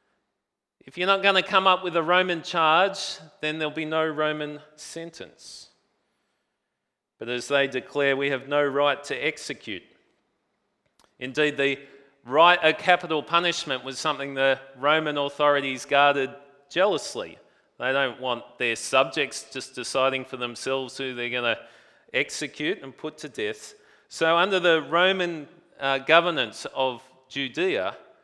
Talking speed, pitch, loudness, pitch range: 140 wpm, 150 Hz, -24 LUFS, 135-170 Hz